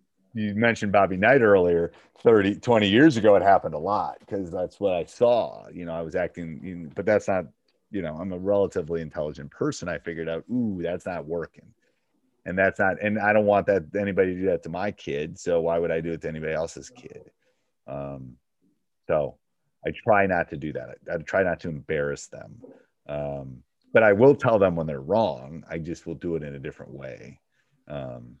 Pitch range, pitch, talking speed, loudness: 75-100 Hz, 85 Hz, 210 wpm, -24 LUFS